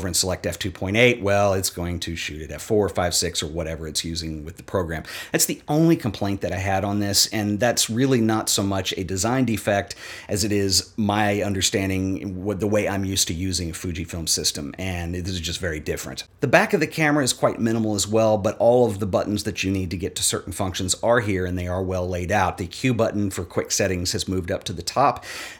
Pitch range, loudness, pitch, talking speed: 90-105 Hz, -22 LUFS, 95 Hz, 240 wpm